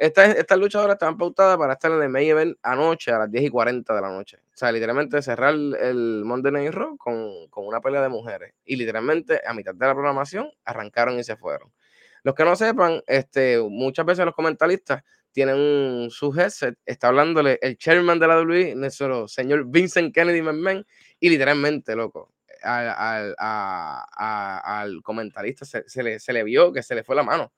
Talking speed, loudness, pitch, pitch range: 200 wpm, -21 LUFS, 150 Hz, 135-180 Hz